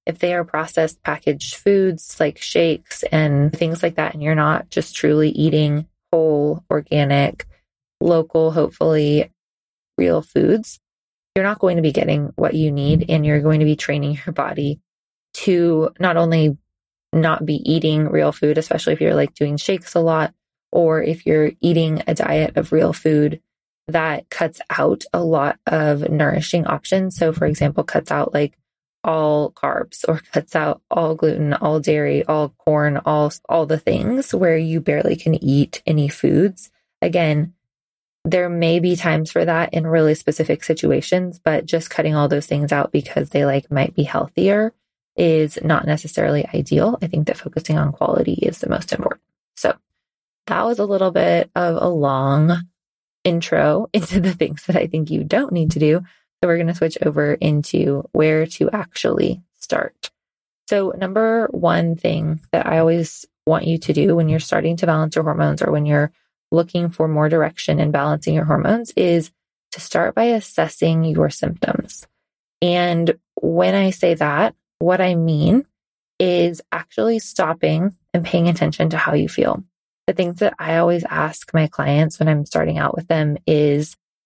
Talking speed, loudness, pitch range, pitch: 170 wpm, -18 LUFS, 150-175 Hz, 160 Hz